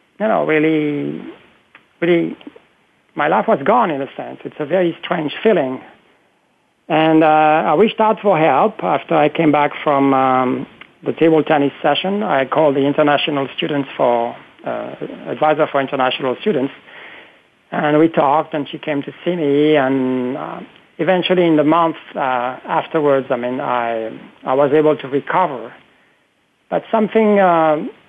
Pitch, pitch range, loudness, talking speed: 150 Hz, 140-165 Hz, -16 LUFS, 155 wpm